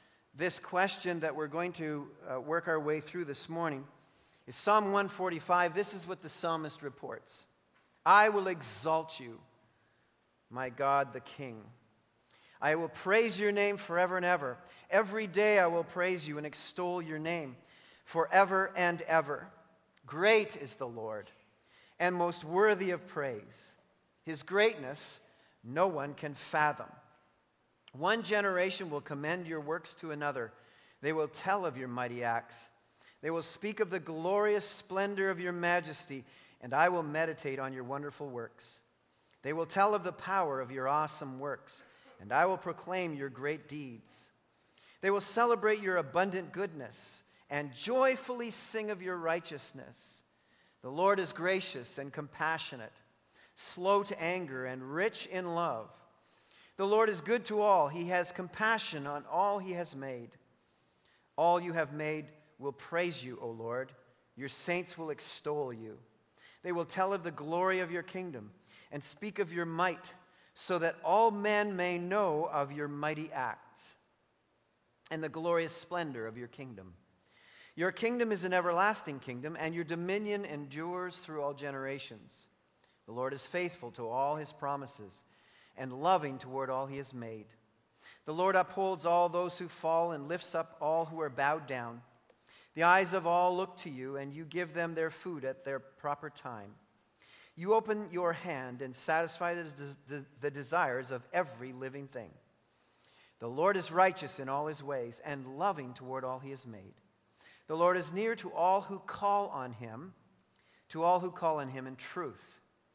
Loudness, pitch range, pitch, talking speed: -34 LUFS, 140-185 Hz, 165 Hz, 160 wpm